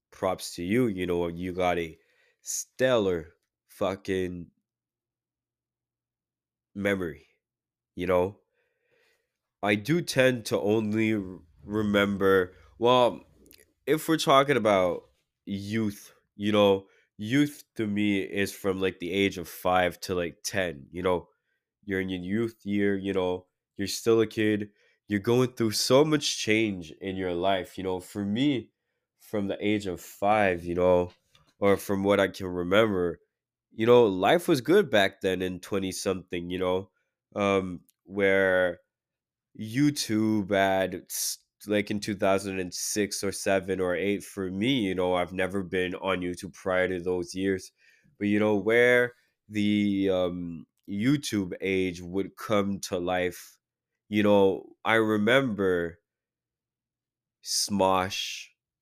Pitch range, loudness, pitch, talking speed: 90-105 Hz, -27 LUFS, 95 Hz, 140 wpm